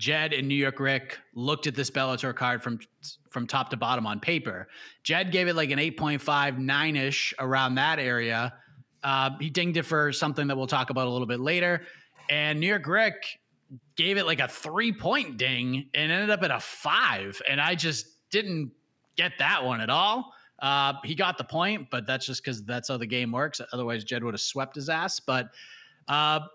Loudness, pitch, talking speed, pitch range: -27 LUFS, 140 Hz, 210 wpm, 130-160 Hz